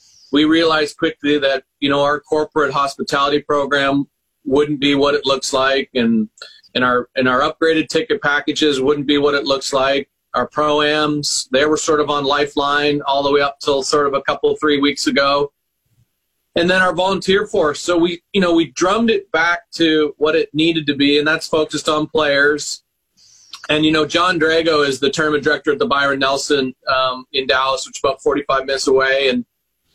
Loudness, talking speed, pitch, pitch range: -16 LUFS, 195 wpm, 145 Hz, 140-155 Hz